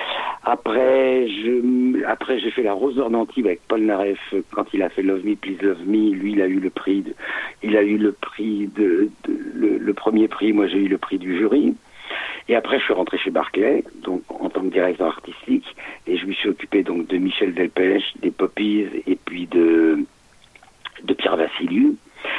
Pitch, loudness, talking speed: 110 Hz, -21 LUFS, 200 wpm